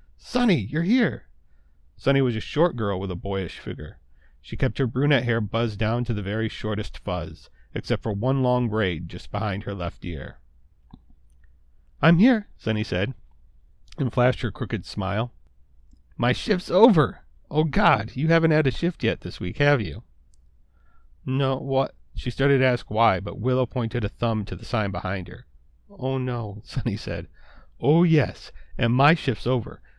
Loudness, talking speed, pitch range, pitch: -24 LUFS, 170 wpm, 85-130 Hz, 110 Hz